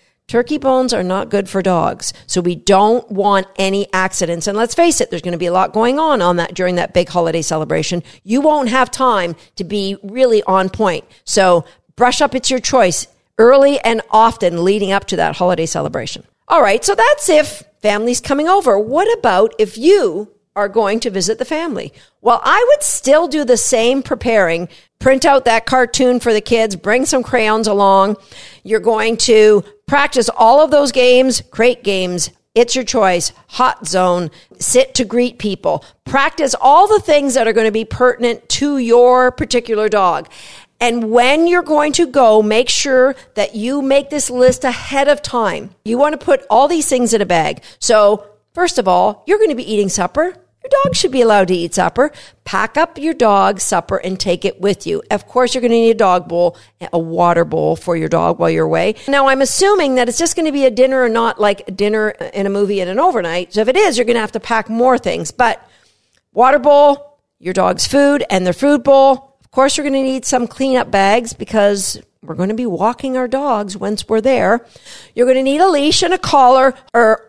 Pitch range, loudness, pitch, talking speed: 195-270 Hz, -14 LUFS, 235 Hz, 205 wpm